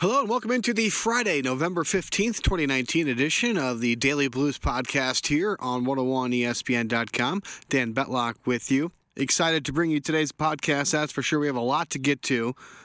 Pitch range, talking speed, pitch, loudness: 130-165 Hz, 180 wpm, 140 Hz, -25 LUFS